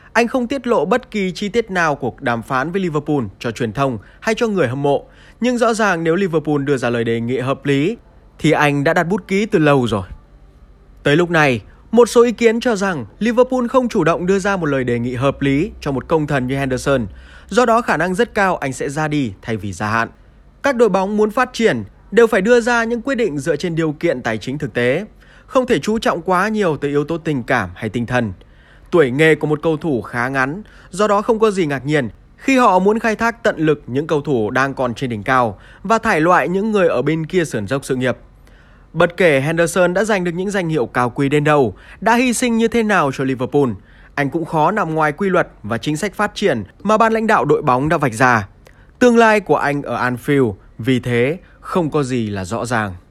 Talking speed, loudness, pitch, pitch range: 245 wpm, -17 LUFS, 150 Hz, 125-210 Hz